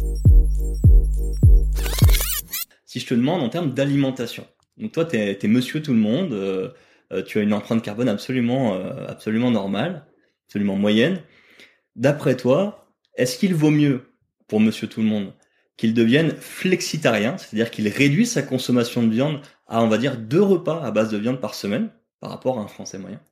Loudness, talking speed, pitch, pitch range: -21 LUFS, 170 wpm, 125 Hz, 105-150 Hz